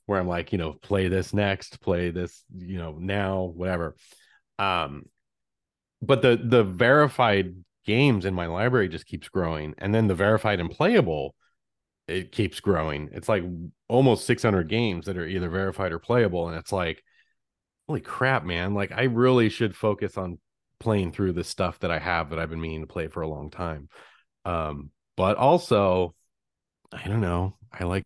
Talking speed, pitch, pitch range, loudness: 180 wpm, 95 Hz, 85-110 Hz, -25 LUFS